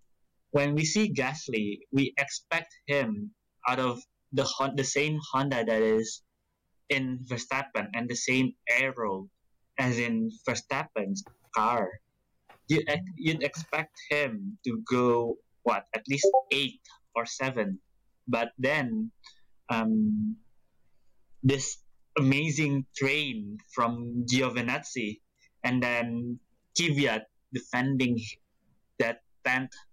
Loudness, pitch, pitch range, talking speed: -29 LUFS, 130 Hz, 120-145 Hz, 100 wpm